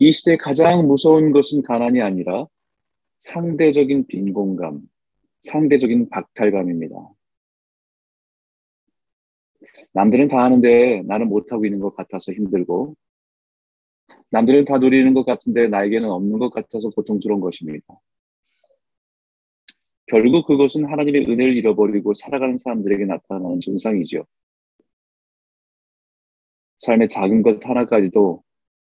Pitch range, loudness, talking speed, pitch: 100-140 Hz, -17 LUFS, 265 characters per minute, 120 Hz